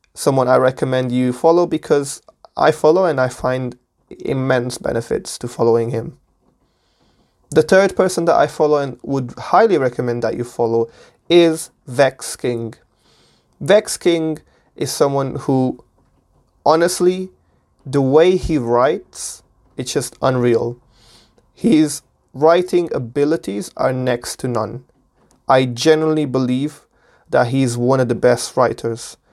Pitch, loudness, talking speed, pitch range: 130 Hz, -17 LUFS, 125 wpm, 120-155 Hz